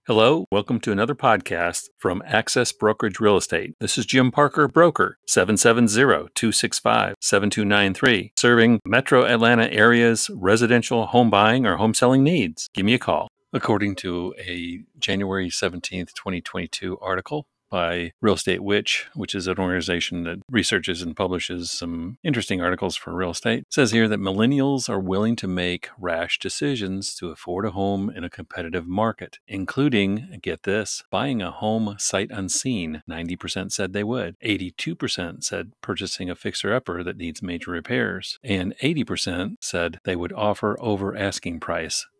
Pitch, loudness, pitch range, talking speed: 100 Hz, -22 LUFS, 90-115 Hz, 155 wpm